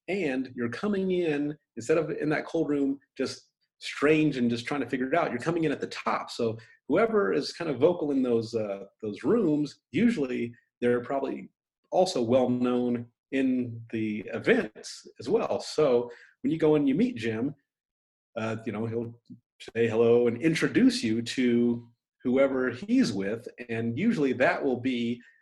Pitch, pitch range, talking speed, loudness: 125 Hz, 120-150 Hz, 170 wpm, -28 LUFS